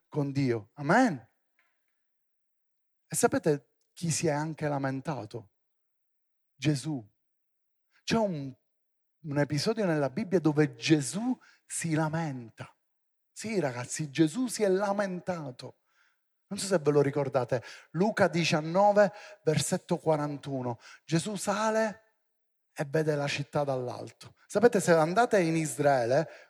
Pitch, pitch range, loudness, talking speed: 155 Hz, 145-200 Hz, -29 LUFS, 110 wpm